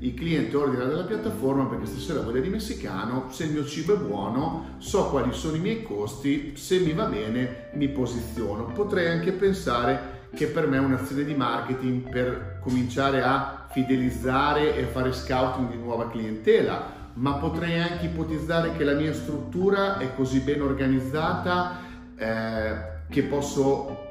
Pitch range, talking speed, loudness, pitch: 125-155 Hz, 155 wpm, -26 LUFS, 135 Hz